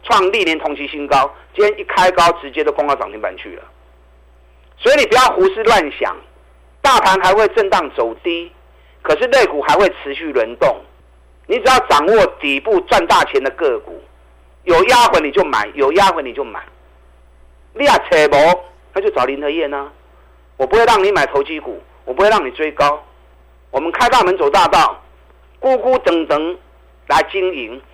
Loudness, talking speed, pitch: -14 LUFS, 250 characters per minute, 140 Hz